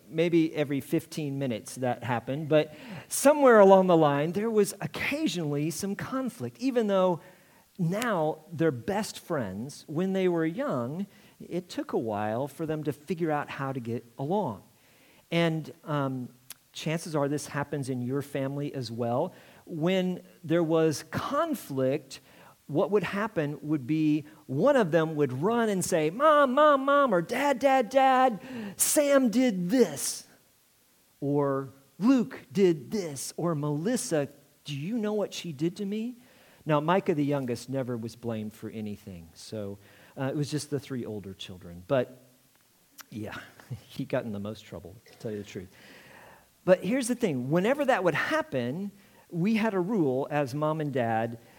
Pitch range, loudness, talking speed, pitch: 135-200 Hz, -28 LUFS, 160 wpm, 155 Hz